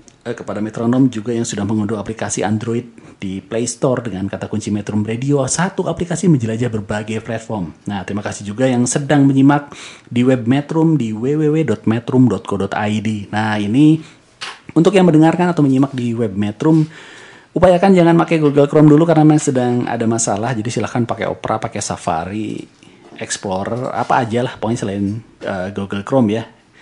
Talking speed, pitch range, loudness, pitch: 155 wpm, 105-145 Hz, -16 LUFS, 120 Hz